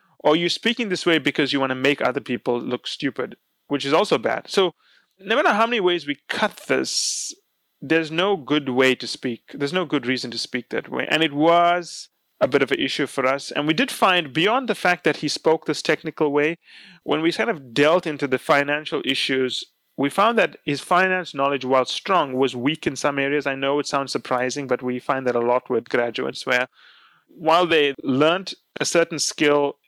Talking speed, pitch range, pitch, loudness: 215 wpm, 135-170 Hz, 145 Hz, -21 LUFS